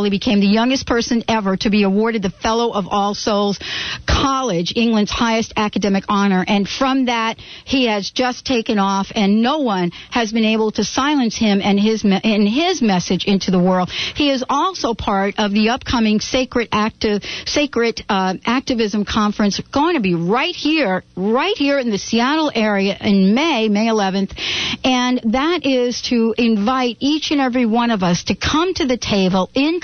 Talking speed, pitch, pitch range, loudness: 180 wpm, 225 Hz, 200-255 Hz, -17 LUFS